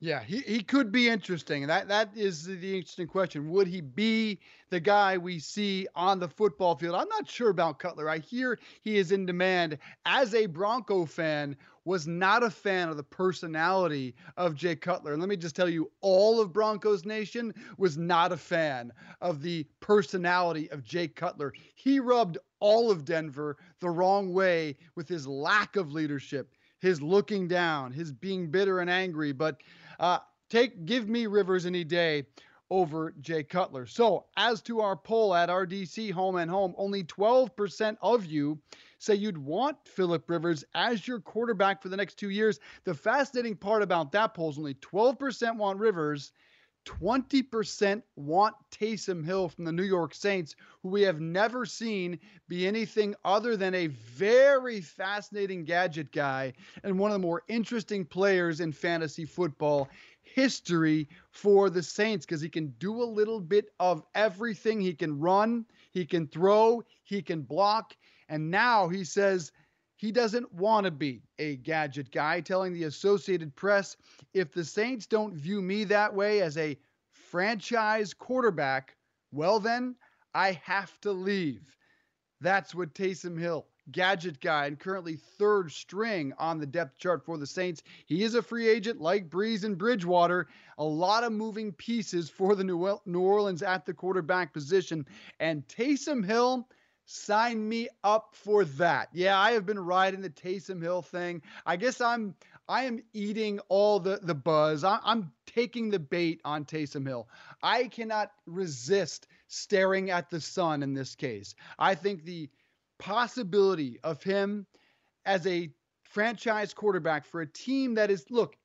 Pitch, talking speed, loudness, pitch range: 190 Hz, 165 wpm, -29 LUFS, 165-210 Hz